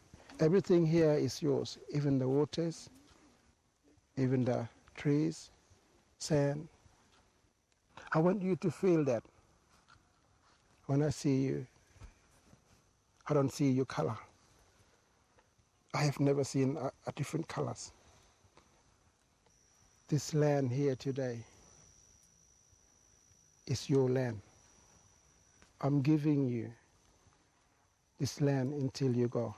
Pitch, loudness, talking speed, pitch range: 135 Hz, -33 LUFS, 100 wpm, 110-145 Hz